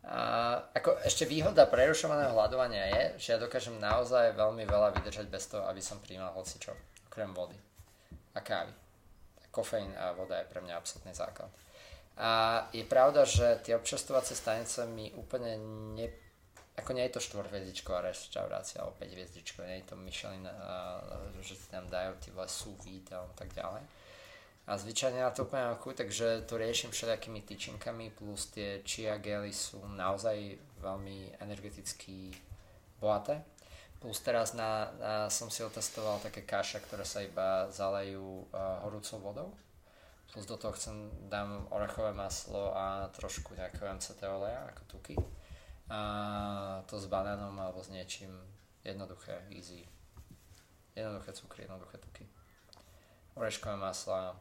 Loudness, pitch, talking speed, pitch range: -36 LUFS, 100 Hz, 145 wpm, 95-110 Hz